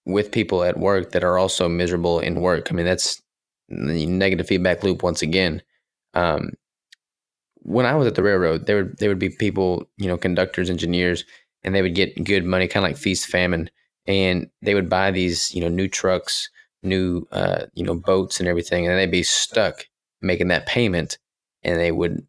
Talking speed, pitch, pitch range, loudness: 195 wpm, 90 Hz, 85-95 Hz, -21 LUFS